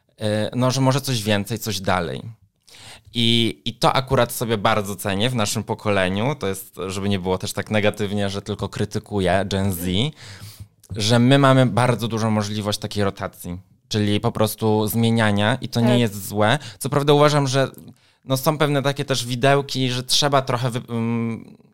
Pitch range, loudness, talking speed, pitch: 105-125 Hz, -21 LUFS, 165 wpm, 110 Hz